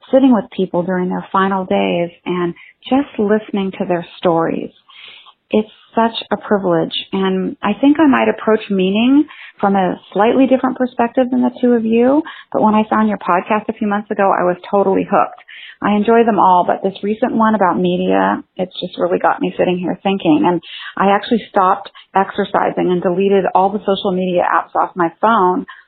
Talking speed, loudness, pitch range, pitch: 190 wpm, -15 LUFS, 185-230 Hz, 200 Hz